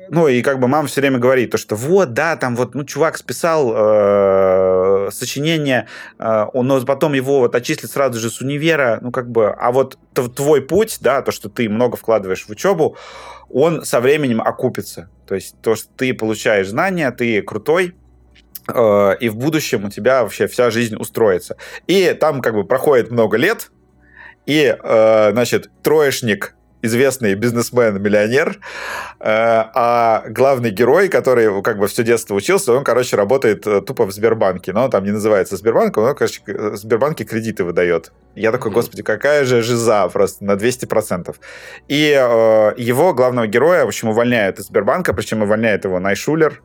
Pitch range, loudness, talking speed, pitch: 105-135 Hz, -16 LUFS, 165 wpm, 120 Hz